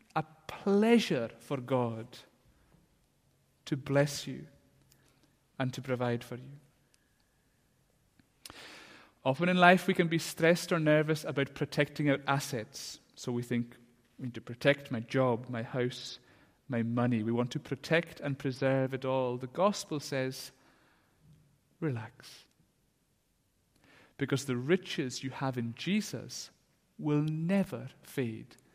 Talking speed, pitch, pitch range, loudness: 125 wpm, 135 Hz, 125-155 Hz, -32 LUFS